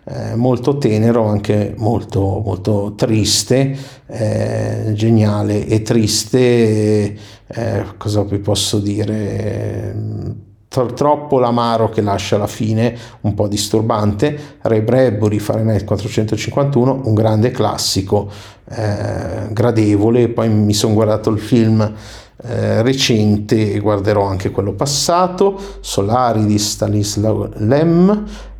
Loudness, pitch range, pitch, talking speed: -16 LUFS, 105-120 Hz, 110 Hz, 110 wpm